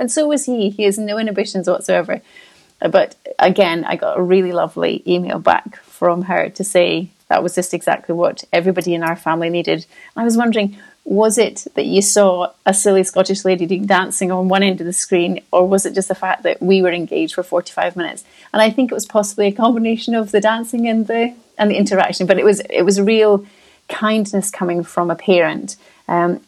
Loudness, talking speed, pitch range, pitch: -16 LUFS, 210 wpm, 180-215 Hz, 195 Hz